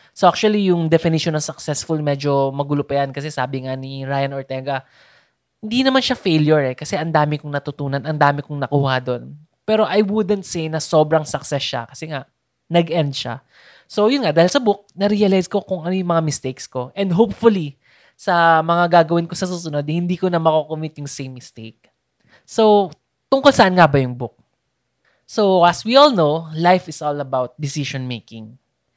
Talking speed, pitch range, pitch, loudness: 190 wpm, 140-180 Hz, 155 Hz, -18 LUFS